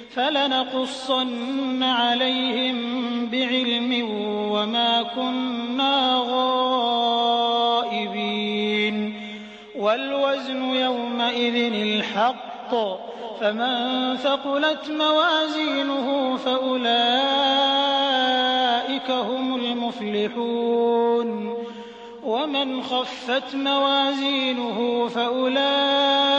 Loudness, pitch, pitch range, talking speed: -22 LUFS, 250 Hz, 235-265 Hz, 45 wpm